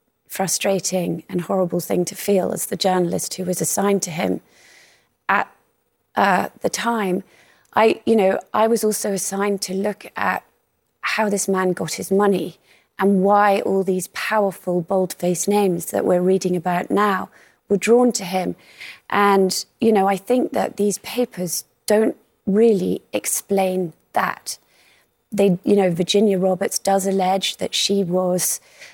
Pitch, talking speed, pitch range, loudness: 195 Hz, 150 wpm, 185-205 Hz, -20 LUFS